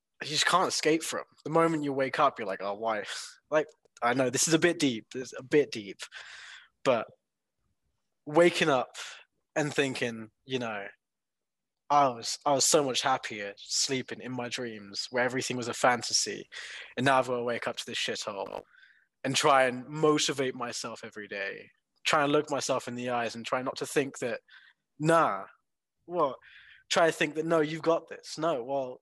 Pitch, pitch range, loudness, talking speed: 130 Hz, 120-155 Hz, -29 LUFS, 190 wpm